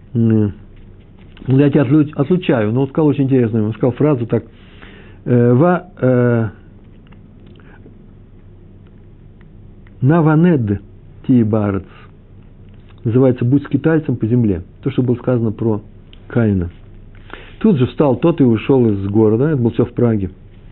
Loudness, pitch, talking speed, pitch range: -15 LUFS, 110 Hz, 120 wpm, 100-130 Hz